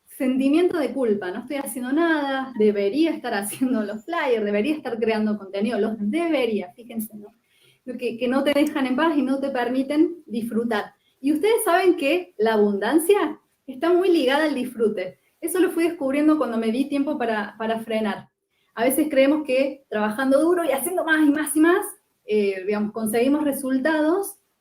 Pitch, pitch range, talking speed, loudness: 265 Hz, 220-310 Hz, 175 wpm, -22 LUFS